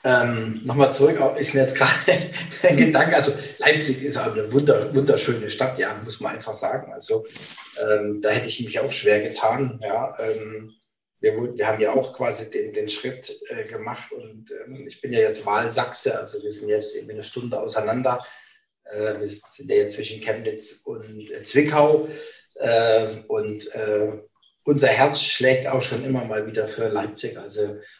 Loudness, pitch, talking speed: -22 LUFS, 135 Hz, 170 wpm